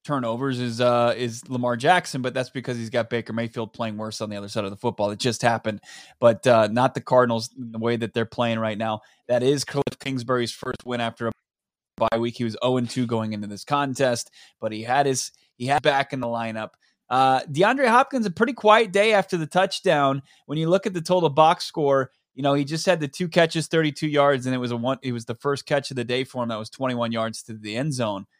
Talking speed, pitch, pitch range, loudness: 245 wpm, 125 Hz, 115-145 Hz, -23 LUFS